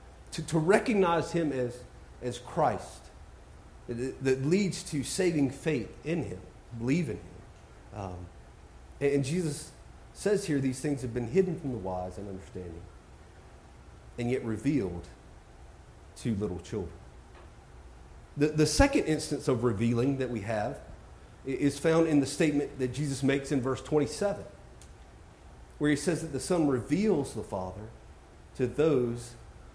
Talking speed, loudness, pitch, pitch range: 140 wpm, -30 LUFS, 130 Hz, 95-150 Hz